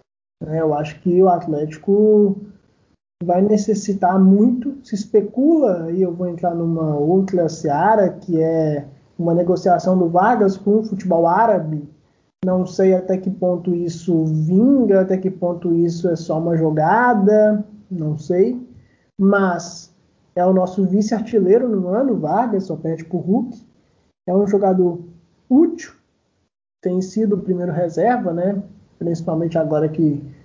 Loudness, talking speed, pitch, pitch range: -18 LUFS, 135 wpm, 185 Hz, 170-205 Hz